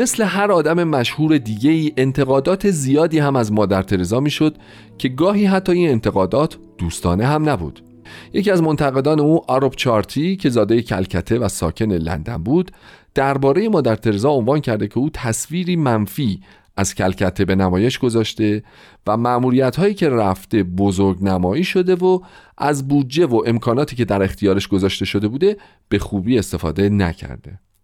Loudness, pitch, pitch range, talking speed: -18 LUFS, 120 Hz, 100-150 Hz, 155 wpm